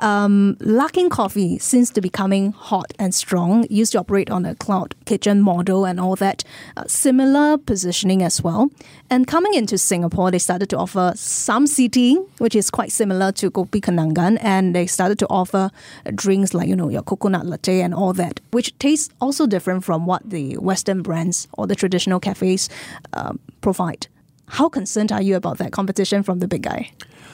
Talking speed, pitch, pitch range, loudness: 185 wpm, 195 Hz, 185-225 Hz, -19 LUFS